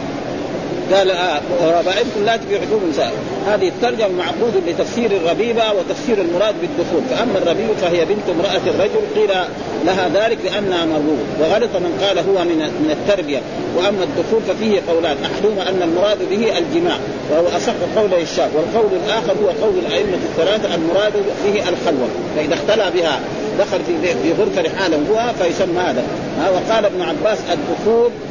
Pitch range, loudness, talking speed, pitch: 175-225 Hz, -17 LUFS, 140 wpm, 195 Hz